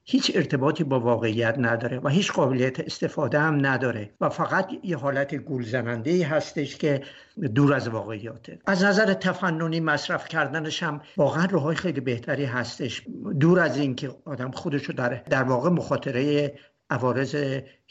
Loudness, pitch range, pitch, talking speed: -25 LUFS, 130-165 Hz, 145 Hz, 145 wpm